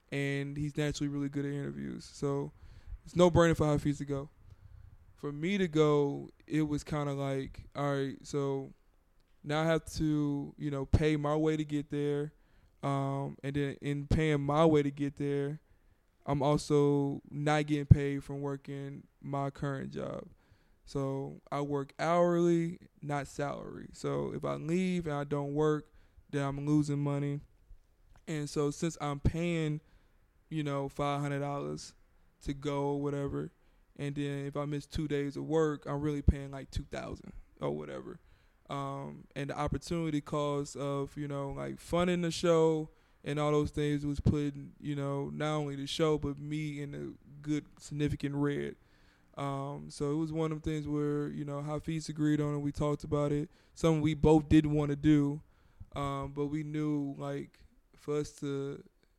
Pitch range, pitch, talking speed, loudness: 140-150 Hz, 145 Hz, 170 wpm, -33 LUFS